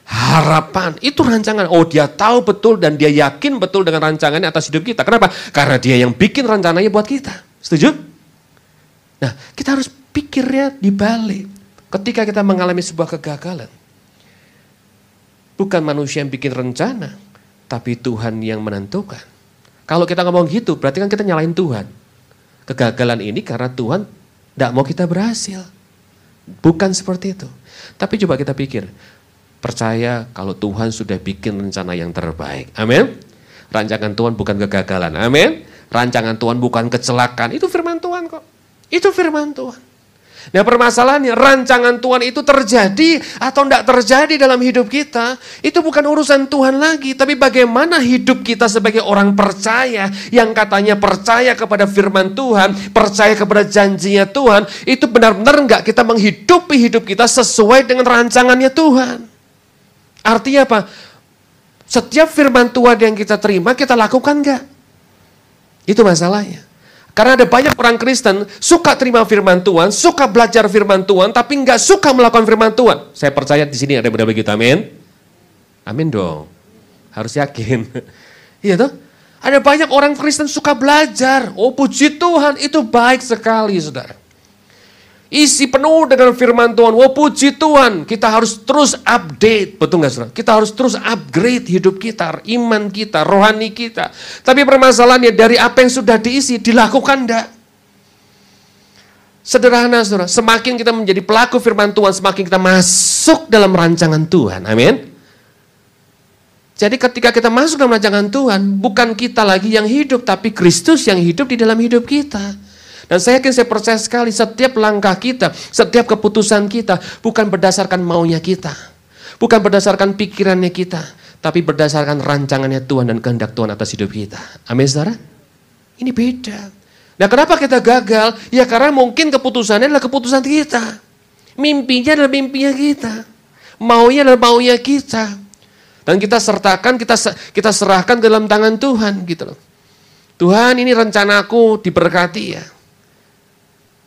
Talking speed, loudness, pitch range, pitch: 140 wpm, -12 LUFS, 165-250 Hz, 215 Hz